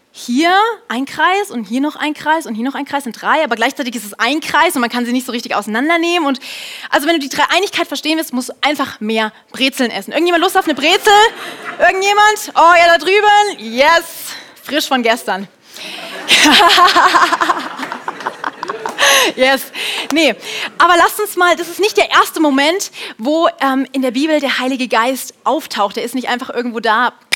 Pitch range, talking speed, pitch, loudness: 250-345 Hz, 185 wpm, 295 Hz, -13 LUFS